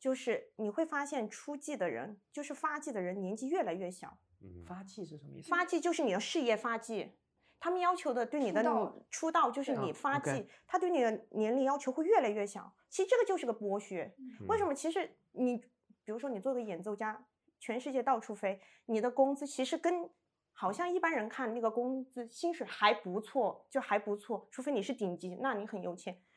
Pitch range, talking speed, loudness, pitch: 210-295 Hz, 305 characters per minute, -35 LUFS, 250 Hz